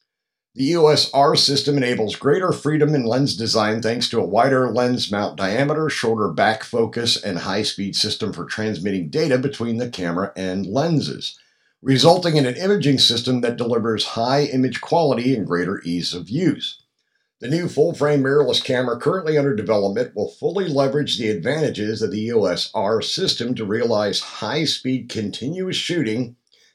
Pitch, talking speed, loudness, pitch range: 125 Hz, 150 wpm, -20 LUFS, 110-145 Hz